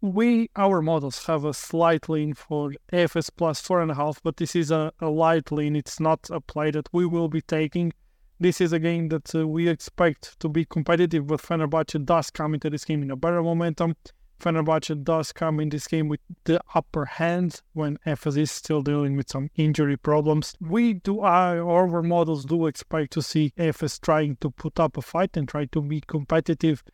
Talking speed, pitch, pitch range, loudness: 205 wpm, 160 Hz, 150-170 Hz, -25 LUFS